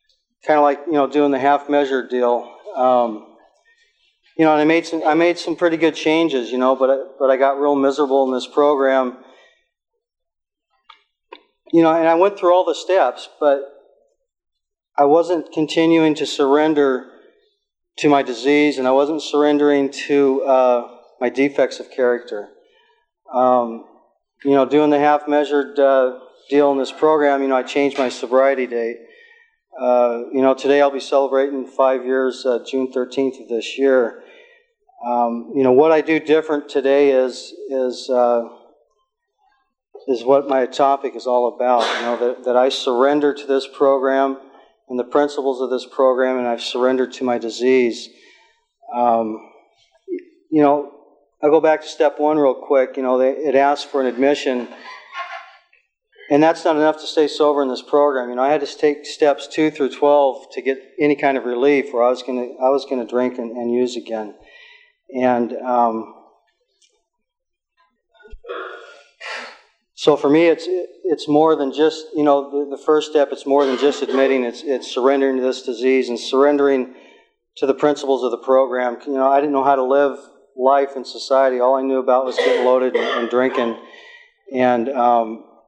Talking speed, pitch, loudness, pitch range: 175 wpm, 140 Hz, -18 LUFS, 130-155 Hz